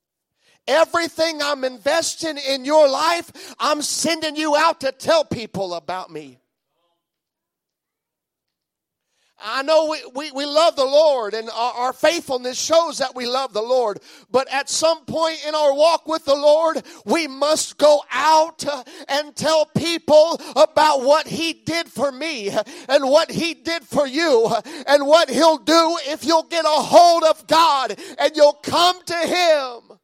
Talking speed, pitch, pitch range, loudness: 155 wpm, 300 Hz, 270-320 Hz, -18 LUFS